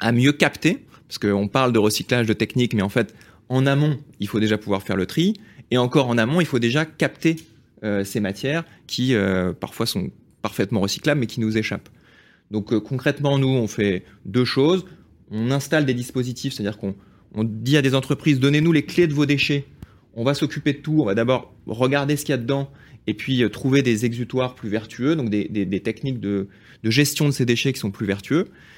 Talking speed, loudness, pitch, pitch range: 220 wpm, -22 LUFS, 125 Hz, 110-140 Hz